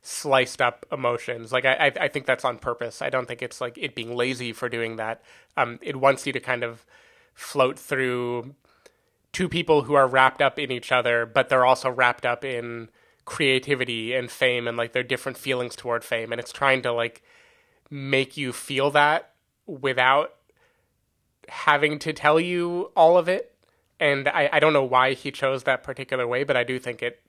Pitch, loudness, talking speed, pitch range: 130 Hz, -23 LUFS, 195 wpm, 120-145 Hz